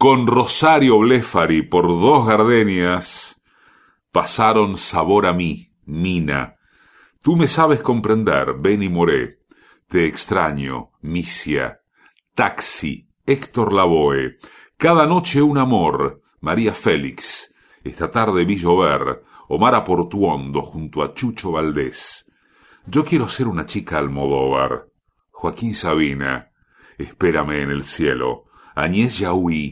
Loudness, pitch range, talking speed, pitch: -18 LUFS, 75-115 Hz, 105 wpm, 90 Hz